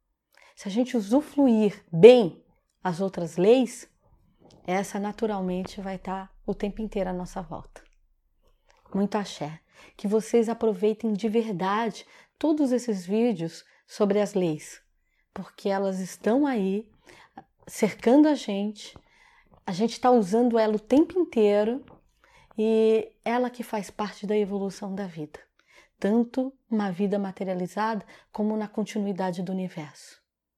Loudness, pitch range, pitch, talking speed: -25 LUFS, 195-230 Hz, 210 Hz, 125 wpm